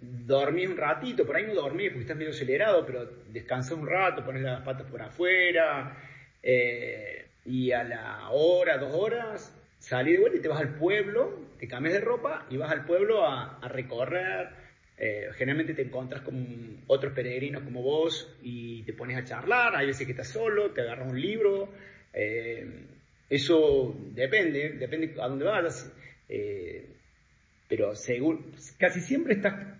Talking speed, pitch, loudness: 165 wpm, 155 Hz, -29 LUFS